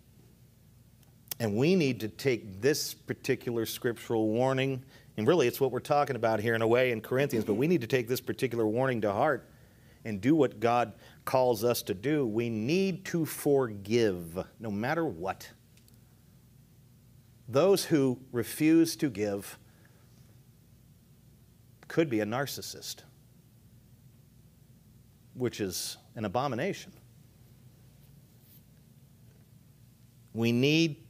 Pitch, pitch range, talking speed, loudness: 125 Hz, 115-135 Hz, 120 wpm, -29 LUFS